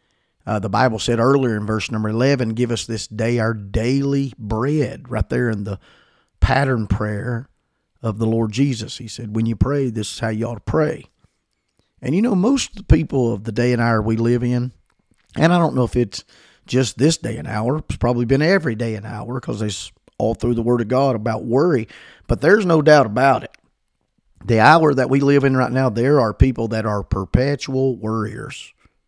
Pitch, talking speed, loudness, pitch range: 120 Hz, 210 wpm, -19 LUFS, 110-135 Hz